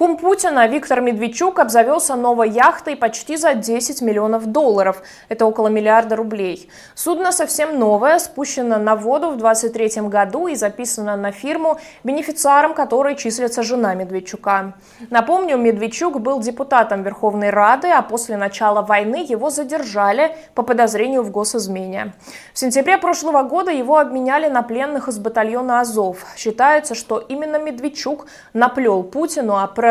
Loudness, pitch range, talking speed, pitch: -17 LUFS, 220-295 Hz, 140 wpm, 245 Hz